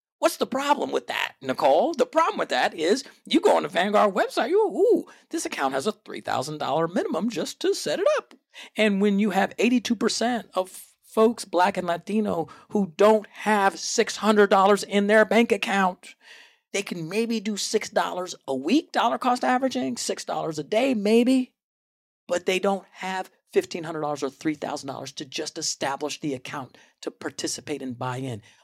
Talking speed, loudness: 165 wpm, -24 LUFS